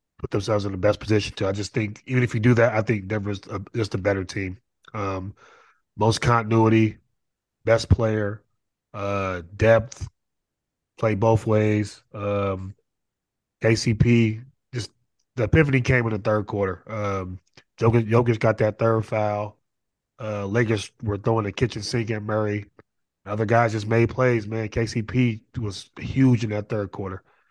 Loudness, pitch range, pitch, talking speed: -23 LUFS, 100-115 Hz, 110 Hz, 160 wpm